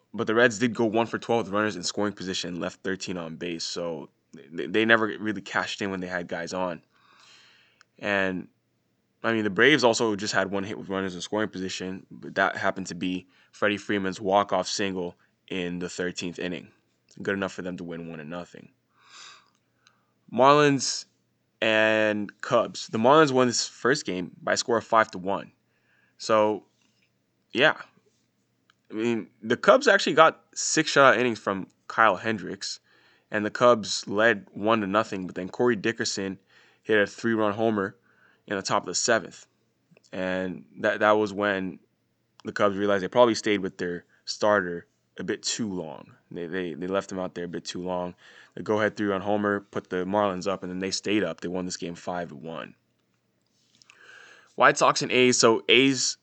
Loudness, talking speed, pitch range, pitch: -25 LUFS, 185 wpm, 90-110 Hz, 100 Hz